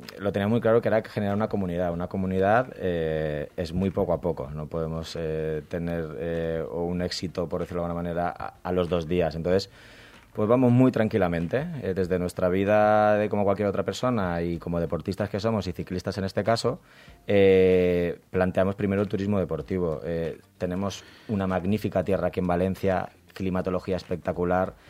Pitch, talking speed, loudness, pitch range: 95 Hz, 180 wpm, -26 LUFS, 85-100 Hz